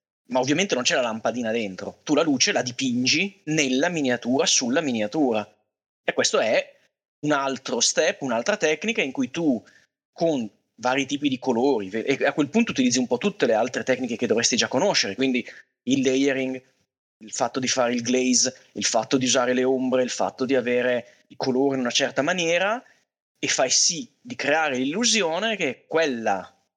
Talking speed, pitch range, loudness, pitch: 180 wpm, 130-210 Hz, -23 LUFS, 135 Hz